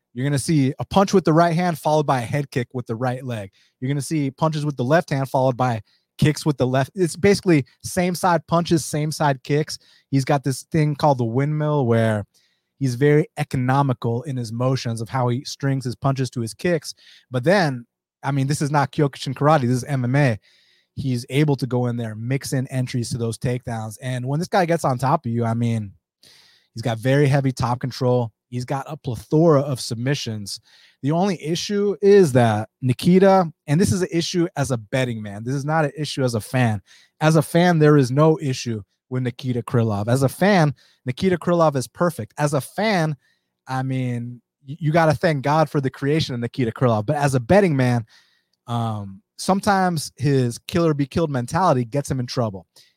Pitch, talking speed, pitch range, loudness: 135 Hz, 210 wpm, 125-155 Hz, -21 LUFS